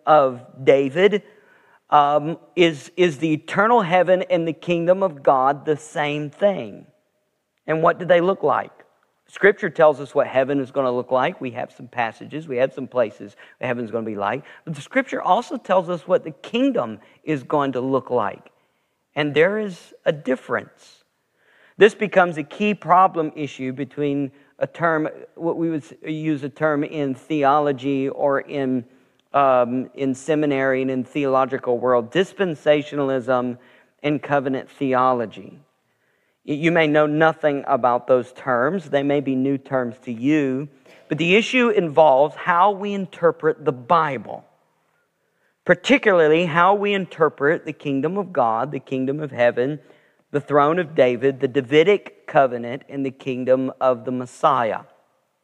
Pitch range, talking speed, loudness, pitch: 130-170 Hz, 155 wpm, -20 LUFS, 145 Hz